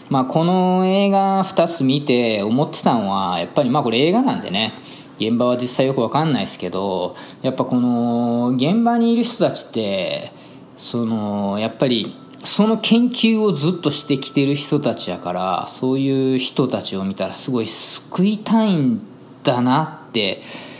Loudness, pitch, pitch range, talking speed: -19 LUFS, 135 Hz, 120-185 Hz, 310 characters per minute